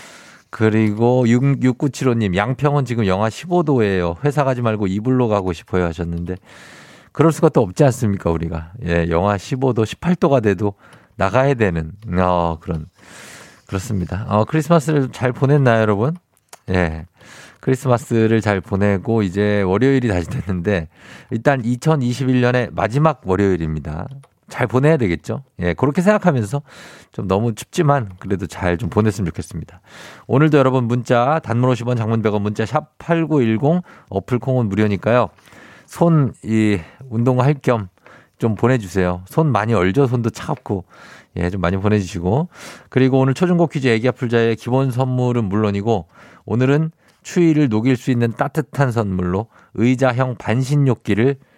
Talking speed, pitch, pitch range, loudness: 305 characters per minute, 115 Hz, 100-135 Hz, -18 LUFS